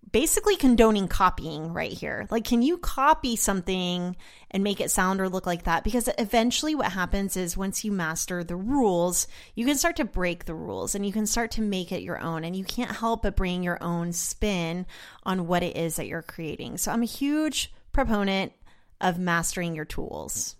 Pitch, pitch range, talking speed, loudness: 190 Hz, 175-230 Hz, 200 wpm, -26 LUFS